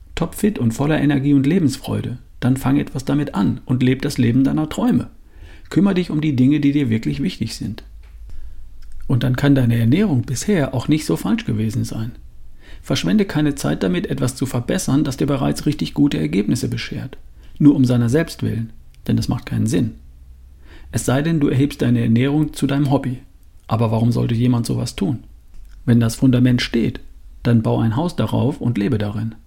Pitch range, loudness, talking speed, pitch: 110-140 Hz, -19 LUFS, 185 wpm, 125 Hz